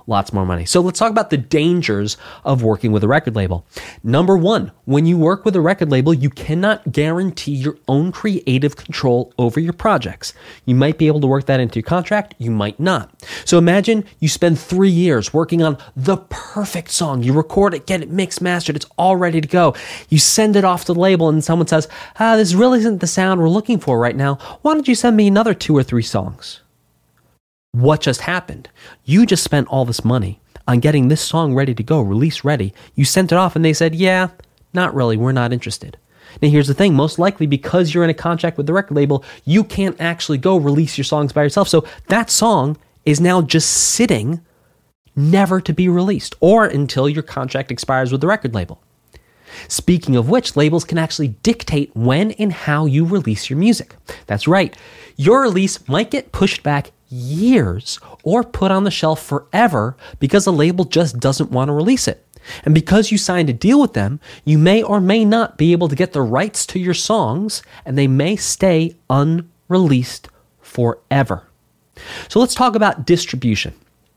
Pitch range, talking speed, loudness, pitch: 135-190 Hz, 200 wpm, -16 LUFS, 160 Hz